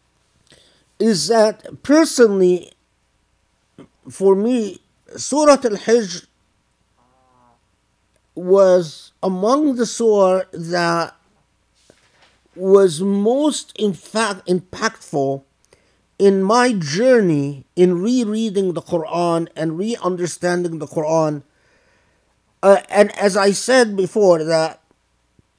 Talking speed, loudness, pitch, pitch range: 85 wpm, -17 LUFS, 185 Hz, 160-220 Hz